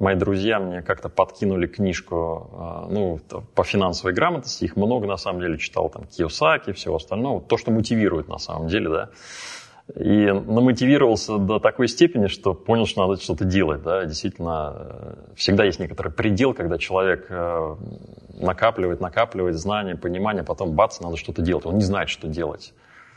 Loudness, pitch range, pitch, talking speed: -22 LUFS, 90-110 Hz, 95 Hz, 160 wpm